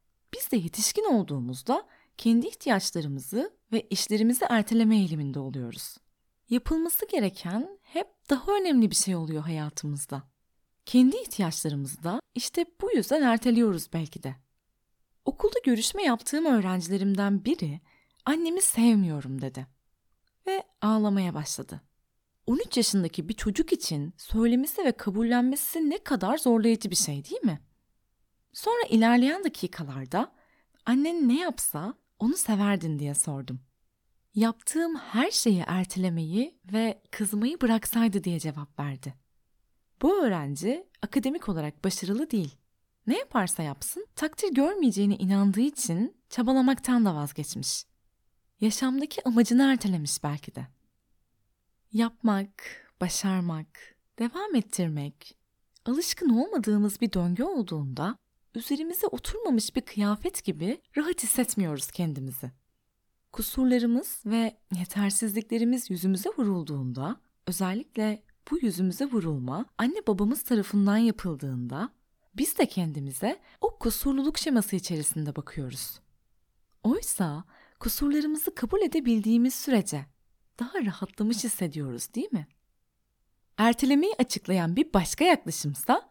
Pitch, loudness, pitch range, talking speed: 215 Hz, -27 LUFS, 165-255 Hz, 105 wpm